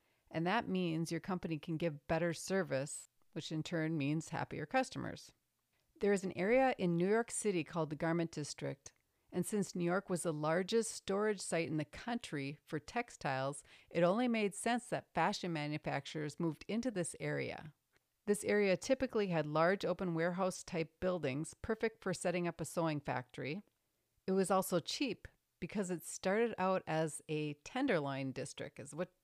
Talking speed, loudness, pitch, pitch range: 170 wpm, -38 LUFS, 170 Hz, 155-195 Hz